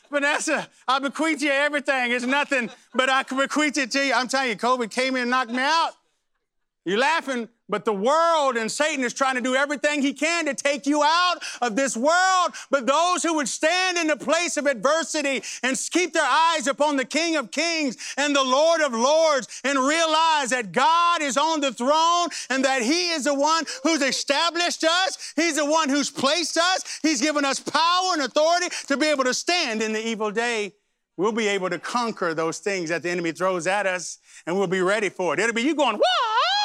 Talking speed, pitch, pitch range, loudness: 215 wpm, 285 Hz, 250-320 Hz, -22 LUFS